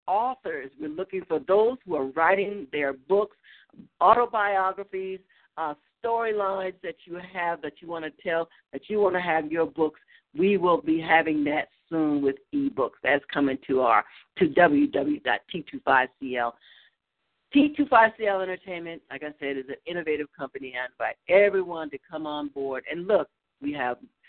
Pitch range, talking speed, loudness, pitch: 150-200 Hz, 155 wpm, -26 LUFS, 170 Hz